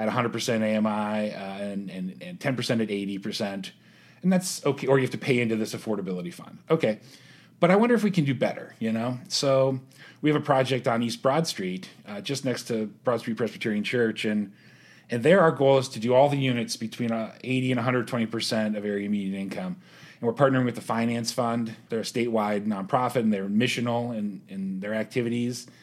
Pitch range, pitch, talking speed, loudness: 110-135 Hz, 120 Hz, 205 wpm, -26 LUFS